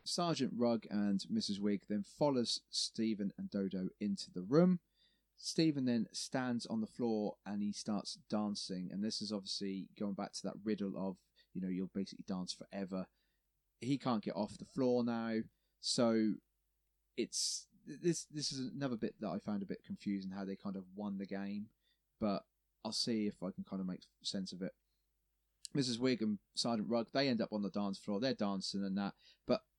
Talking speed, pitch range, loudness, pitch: 190 wpm, 100-130 Hz, -39 LUFS, 105 Hz